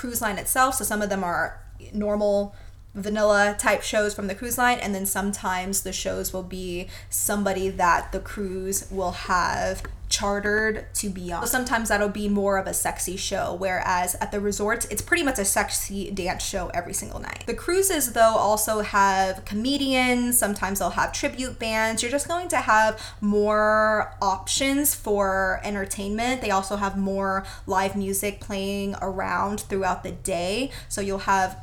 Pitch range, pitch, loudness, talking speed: 190-220 Hz, 205 Hz, -24 LUFS, 170 wpm